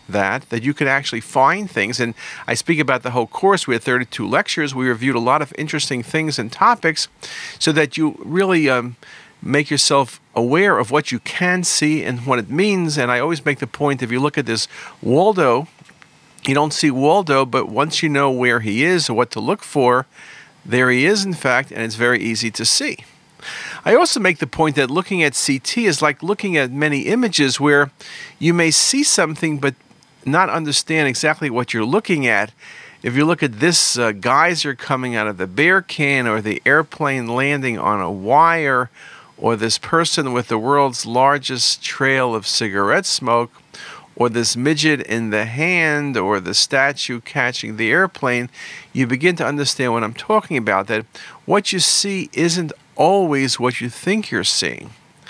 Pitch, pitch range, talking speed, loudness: 140 Hz, 125-160 Hz, 190 wpm, -17 LUFS